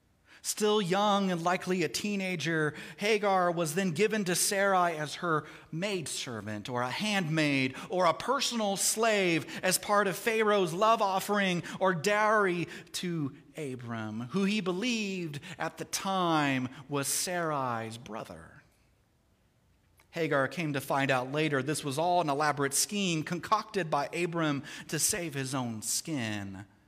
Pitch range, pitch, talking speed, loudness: 140-195 Hz, 170 Hz, 135 wpm, -30 LUFS